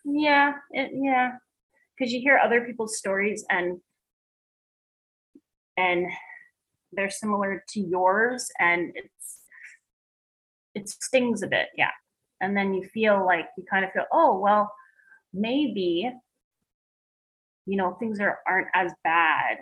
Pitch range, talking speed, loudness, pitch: 190-260 Hz, 125 wpm, -25 LUFS, 210 Hz